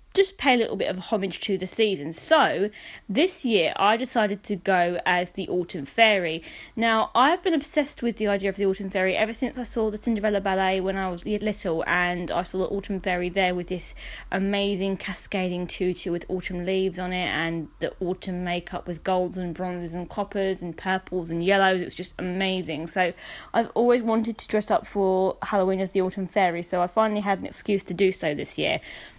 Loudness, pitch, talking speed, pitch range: -25 LUFS, 190 Hz, 210 wpm, 180-215 Hz